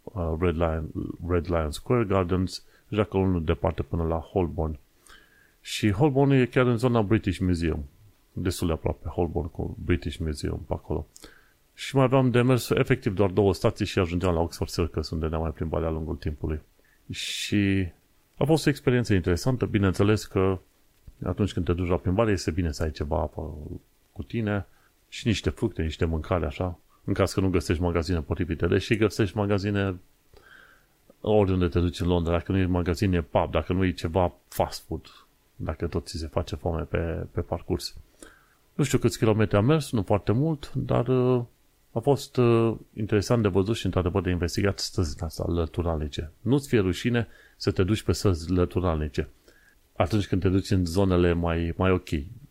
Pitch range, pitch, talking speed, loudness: 85-110 Hz, 95 Hz, 180 wpm, -26 LUFS